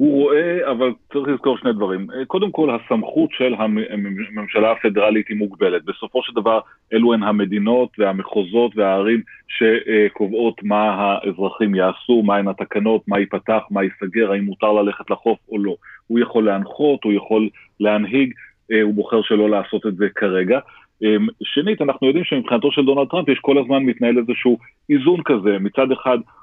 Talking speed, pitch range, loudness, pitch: 155 wpm, 105-130 Hz, -18 LUFS, 110 Hz